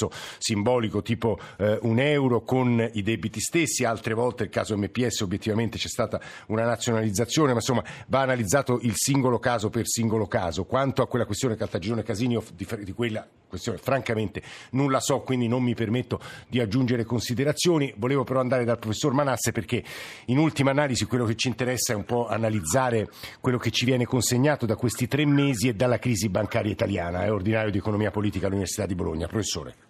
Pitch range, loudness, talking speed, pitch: 110-125 Hz, -25 LUFS, 185 wpm, 115 Hz